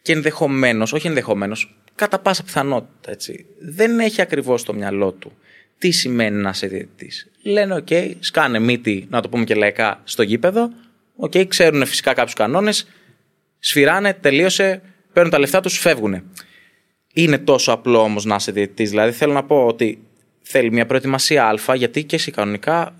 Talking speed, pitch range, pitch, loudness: 160 wpm, 110-180 Hz, 140 Hz, -17 LUFS